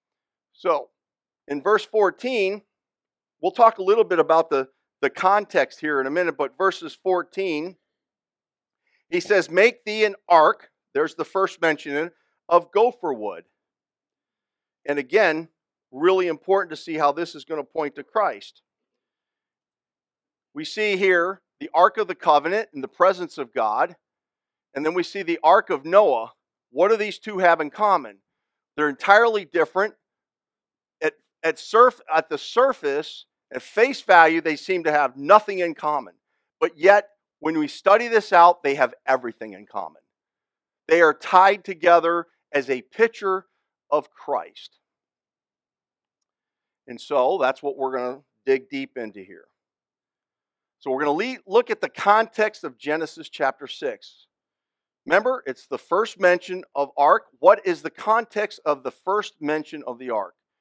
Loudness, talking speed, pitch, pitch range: -21 LUFS, 155 wpm, 185 Hz, 155-215 Hz